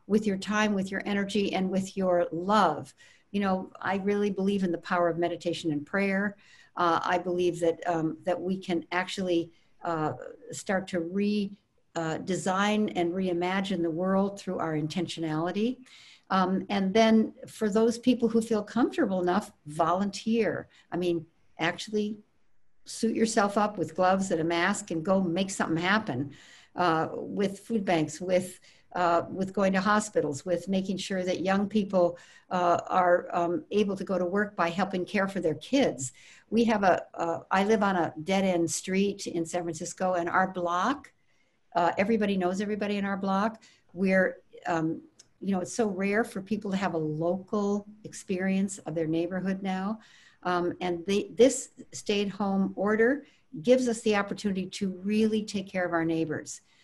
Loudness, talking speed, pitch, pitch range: -28 LUFS, 170 wpm, 190 Hz, 175-205 Hz